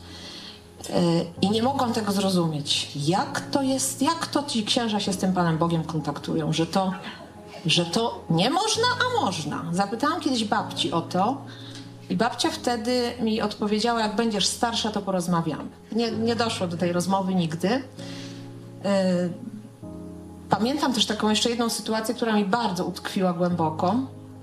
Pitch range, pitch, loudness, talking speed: 175-240 Hz, 205 Hz, -24 LUFS, 145 wpm